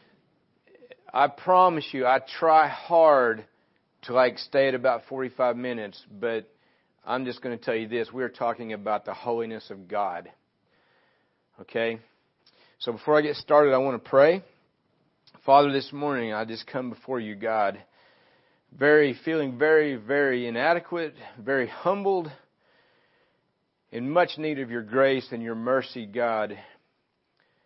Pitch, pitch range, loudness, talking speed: 135 Hz, 120-155 Hz, -25 LUFS, 140 wpm